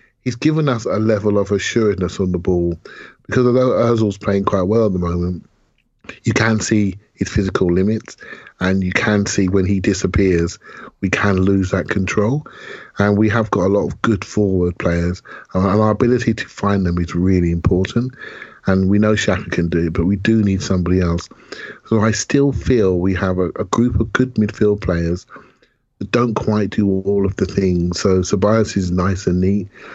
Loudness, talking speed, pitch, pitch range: -17 LUFS, 190 wpm, 100 Hz, 90-110 Hz